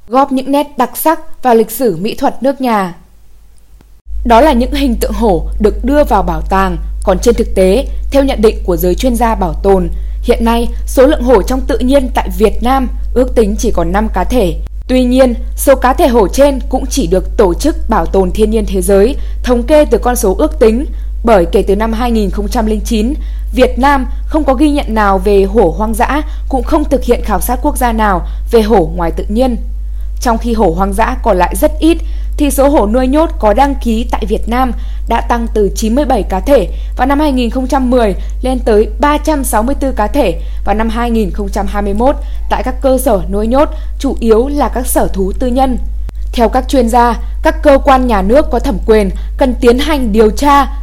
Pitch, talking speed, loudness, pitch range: 240 Hz, 210 wpm, -12 LUFS, 215-275 Hz